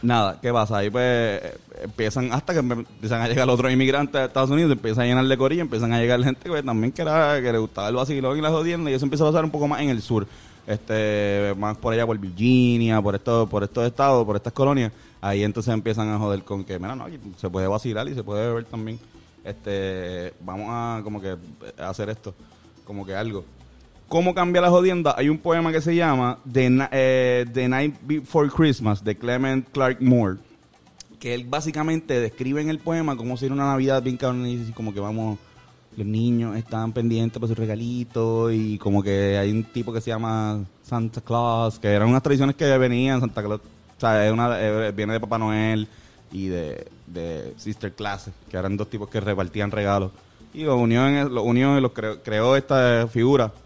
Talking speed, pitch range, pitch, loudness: 210 wpm, 105-130 Hz, 115 Hz, -23 LUFS